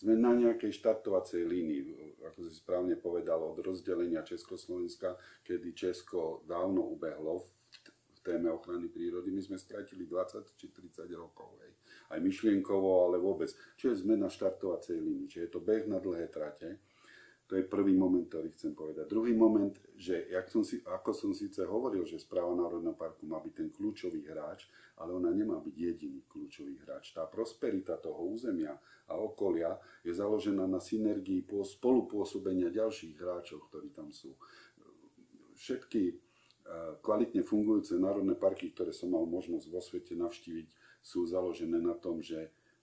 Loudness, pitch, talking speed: -35 LUFS, 315 Hz, 150 wpm